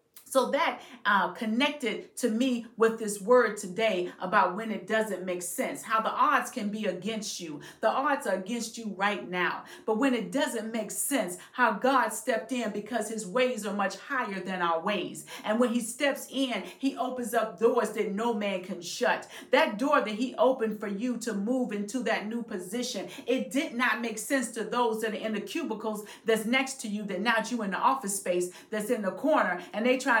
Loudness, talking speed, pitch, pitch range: -29 LUFS, 210 wpm, 225 Hz, 205-250 Hz